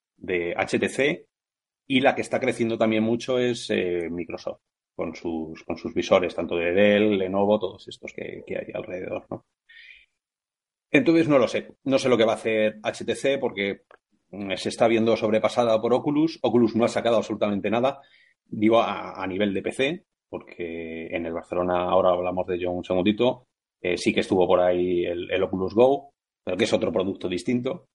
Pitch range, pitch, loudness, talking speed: 90-120 Hz, 105 Hz, -24 LUFS, 180 wpm